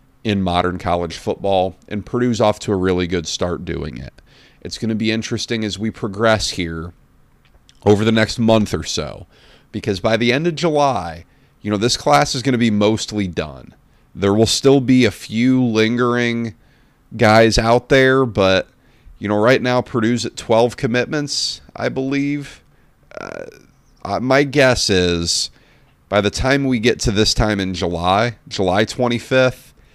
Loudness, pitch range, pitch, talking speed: -17 LUFS, 100-125 Hz, 110 Hz, 165 wpm